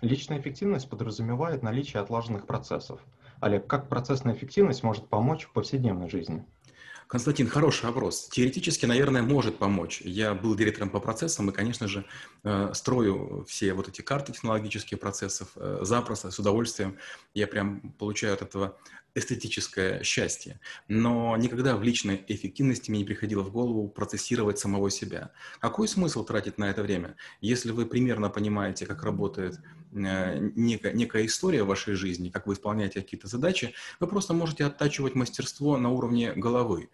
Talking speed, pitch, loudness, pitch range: 145 wpm, 110 Hz, -29 LUFS, 100-130 Hz